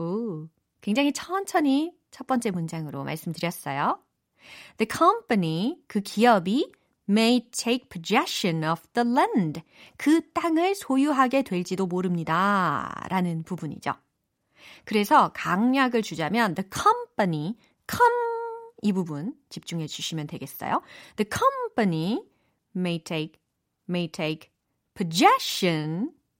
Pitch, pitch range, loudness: 210 Hz, 170-275 Hz, -25 LUFS